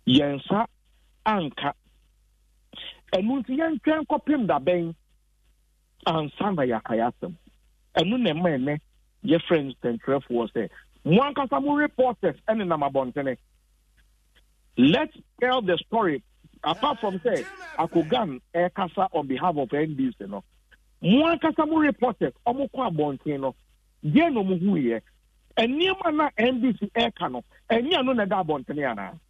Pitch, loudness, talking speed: 180 Hz, -25 LUFS, 145 wpm